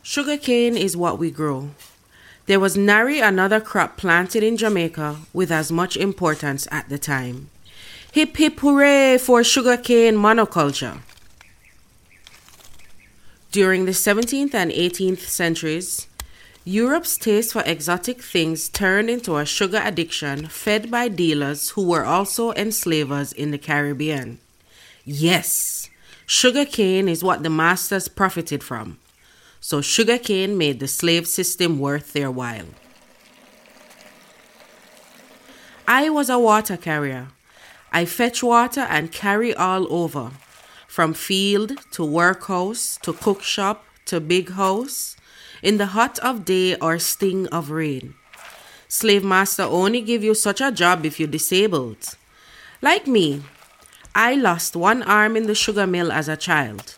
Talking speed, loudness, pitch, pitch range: 130 wpm, -19 LUFS, 180 Hz, 150-215 Hz